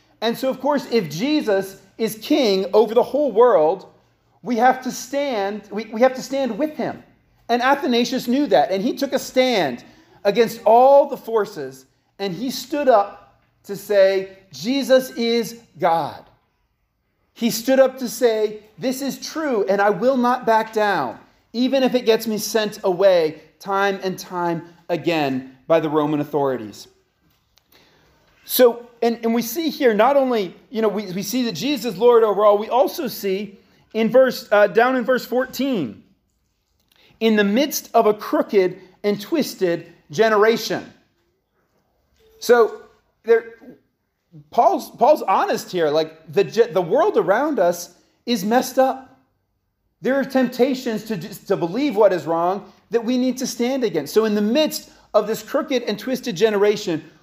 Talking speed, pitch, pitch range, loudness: 160 wpm, 225 Hz, 195-255 Hz, -19 LUFS